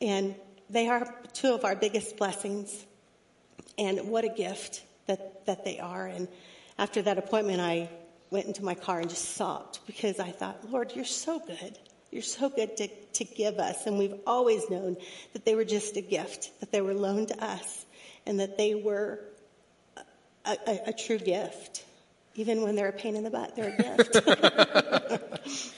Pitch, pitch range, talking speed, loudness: 210 Hz, 195-225 Hz, 180 wpm, -30 LUFS